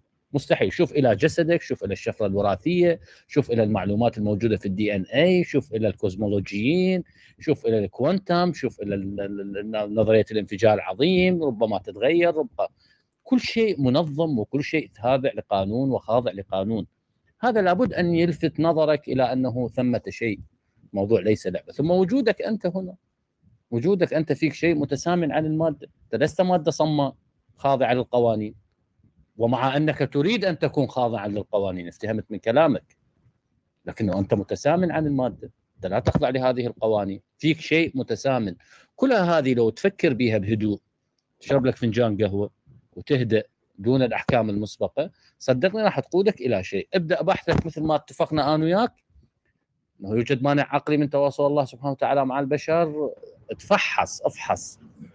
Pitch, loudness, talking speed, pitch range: 135 Hz, -23 LUFS, 145 wpm, 110-165 Hz